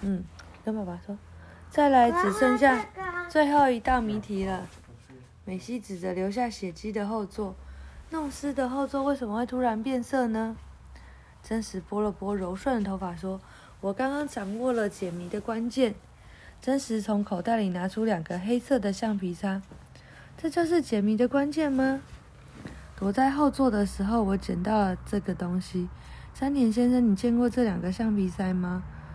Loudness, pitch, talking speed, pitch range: -28 LUFS, 215 Hz, 245 characters per minute, 190-255 Hz